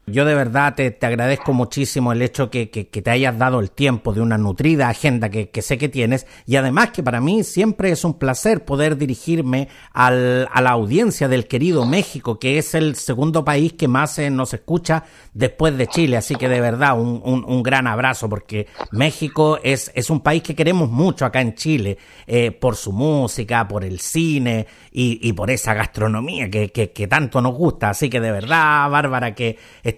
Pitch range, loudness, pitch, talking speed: 120-150 Hz, -18 LUFS, 130 Hz, 205 wpm